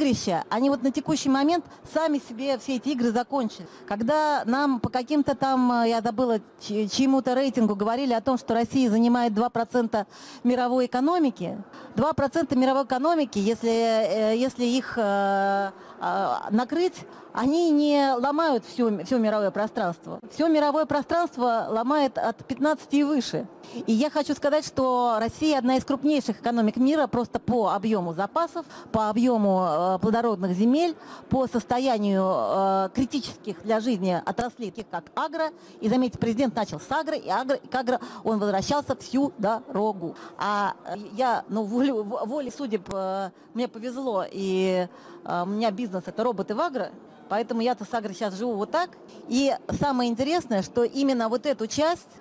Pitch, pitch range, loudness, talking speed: 245 Hz, 215-275 Hz, -25 LUFS, 145 wpm